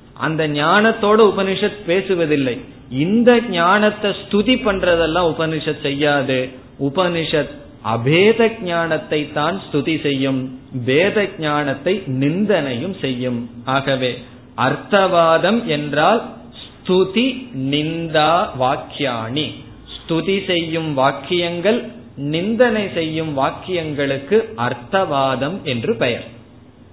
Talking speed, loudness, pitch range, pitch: 75 wpm, -18 LUFS, 135-195 Hz, 160 Hz